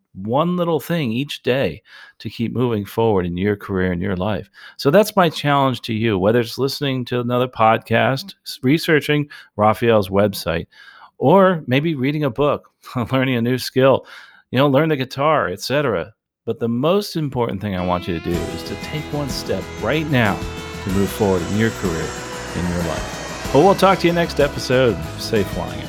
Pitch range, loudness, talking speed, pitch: 100-145 Hz, -19 LUFS, 190 wpm, 125 Hz